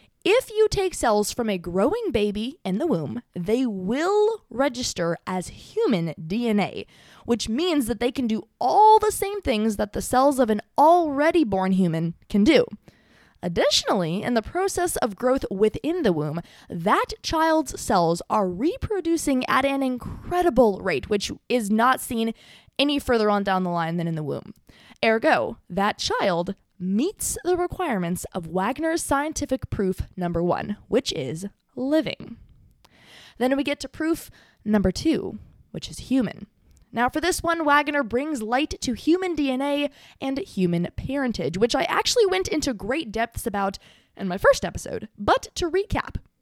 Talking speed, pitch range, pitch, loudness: 160 wpm, 200-315 Hz, 250 Hz, -23 LUFS